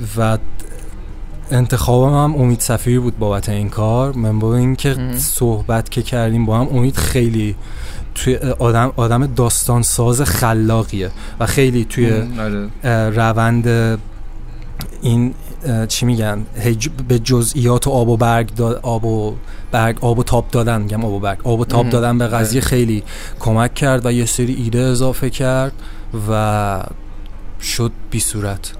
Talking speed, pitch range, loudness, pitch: 145 wpm, 110-125 Hz, -16 LUFS, 115 Hz